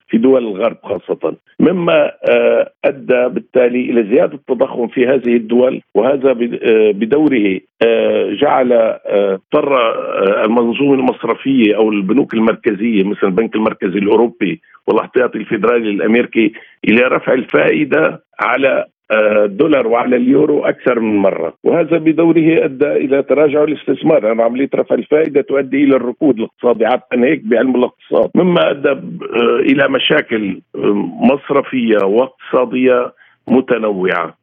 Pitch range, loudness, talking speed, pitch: 115-150 Hz, -13 LUFS, 110 wpm, 130 Hz